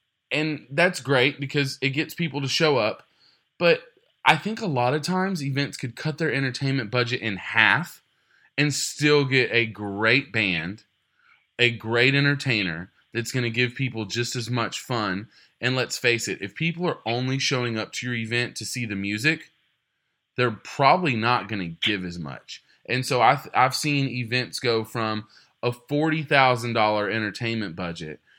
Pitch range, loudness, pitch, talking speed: 110-145 Hz, -24 LUFS, 125 Hz, 170 wpm